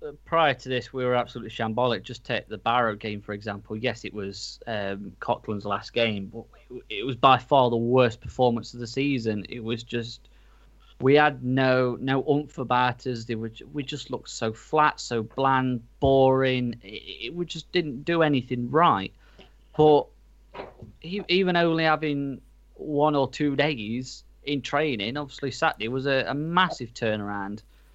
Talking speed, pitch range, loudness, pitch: 165 wpm, 115-145 Hz, -25 LUFS, 125 Hz